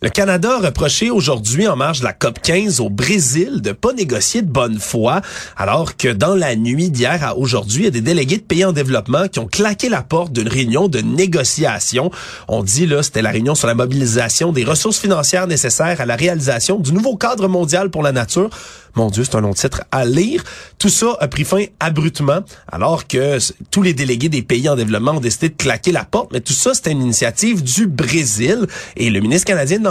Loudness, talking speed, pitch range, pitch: -15 LUFS, 220 wpm, 125-190 Hz, 155 Hz